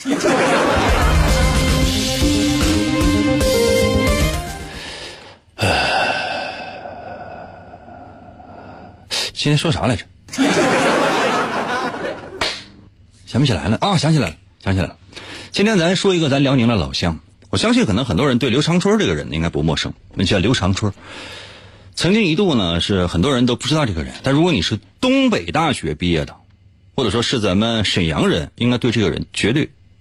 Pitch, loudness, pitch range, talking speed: 100 Hz, -17 LUFS, 85-125 Hz, 210 characters per minute